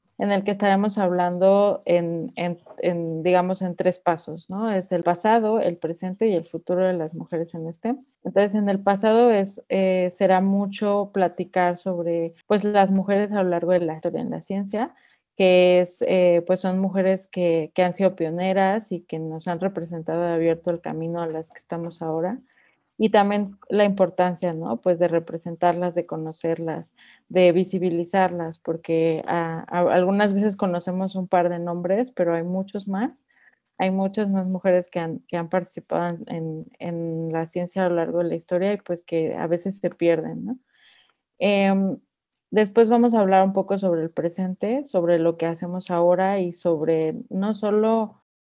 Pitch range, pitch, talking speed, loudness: 170-195 Hz, 180 Hz, 180 wpm, -23 LUFS